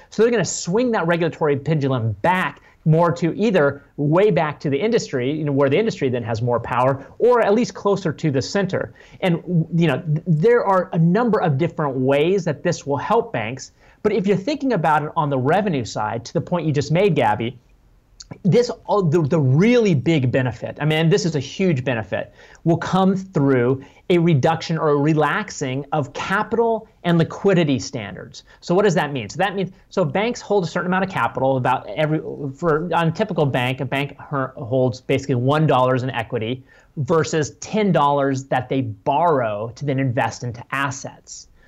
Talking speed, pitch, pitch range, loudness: 185 wpm, 150 Hz, 135-180 Hz, -20 LUFS